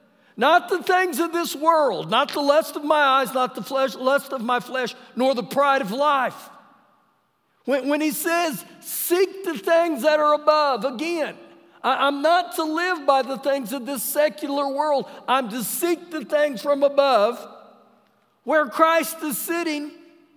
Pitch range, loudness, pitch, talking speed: 270-325 Hz, -21 LUFS, 295 Hz, 170 wpm